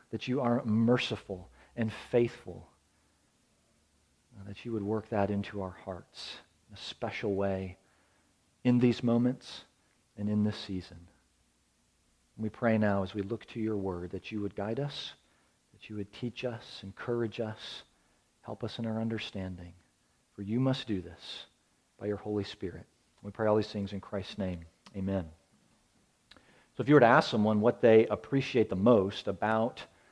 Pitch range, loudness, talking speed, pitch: 90-115 Hz, -31 LUFS, 170 wpm, 105 Hz